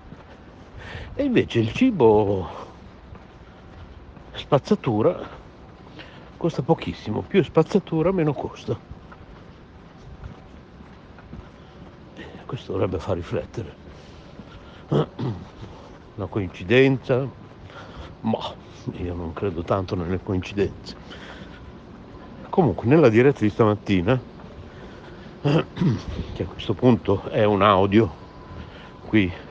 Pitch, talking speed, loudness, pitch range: 105 Hz, 75 wpm, -22 LUFS, 90-130 Hz